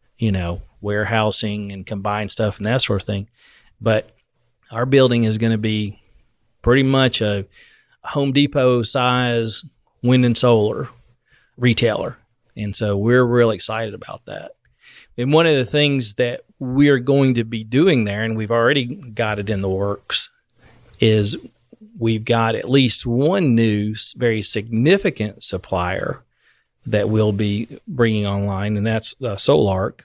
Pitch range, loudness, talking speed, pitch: 105-125 Hz, -19 LUFS, 150 wpm, 115 Hz